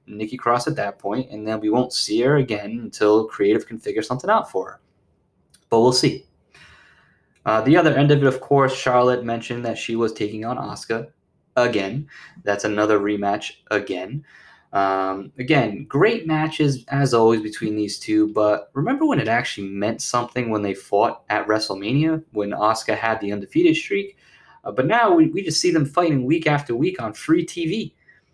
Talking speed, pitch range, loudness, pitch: 180 wpm, 105-155 Hz, -21 LUFS, 120 Hz